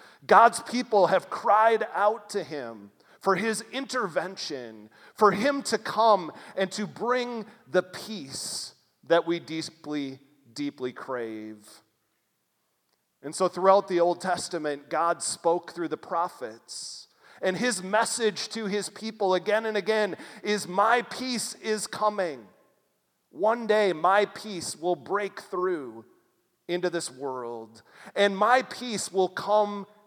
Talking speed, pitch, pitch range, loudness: 130 wpm, 200 Hz, 170-215 Hz, -27 LUFS